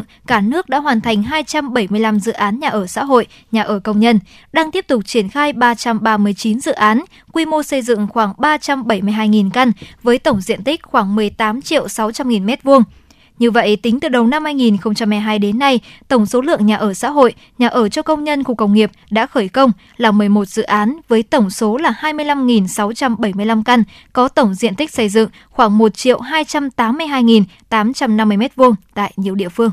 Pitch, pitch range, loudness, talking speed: 230 Hz, 215-265 Hz, -15 LUFS, 180 wpm